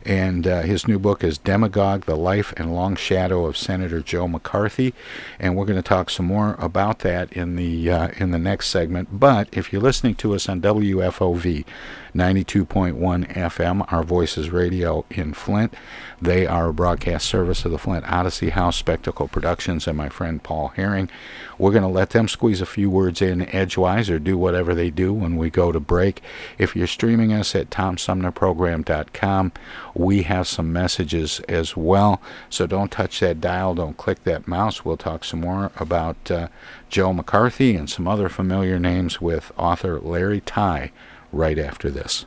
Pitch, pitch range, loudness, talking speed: 90 Hz, 85-100 Hz, -21 LUFS, 180 wpm